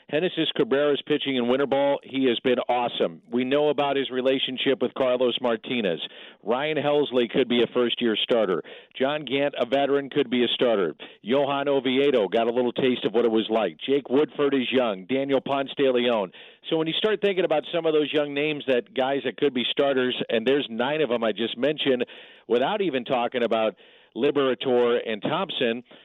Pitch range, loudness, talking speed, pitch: 120-145 Hz, -24 LUFS, 195 wpm, 135 Hz